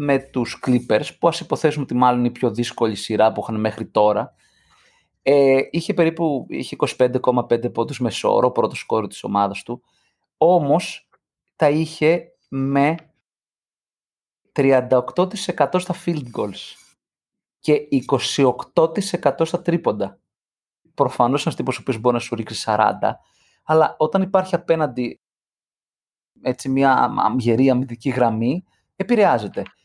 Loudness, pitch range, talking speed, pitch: -20 LUFS, 120-160 Hz, 125 wpm, 135 Hz